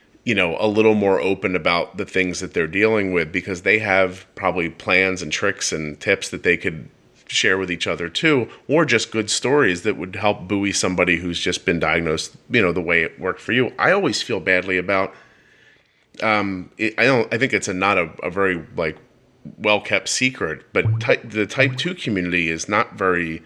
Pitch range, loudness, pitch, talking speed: 90-105 Hz, -20 LUFS, 95 Hz, 205 wpm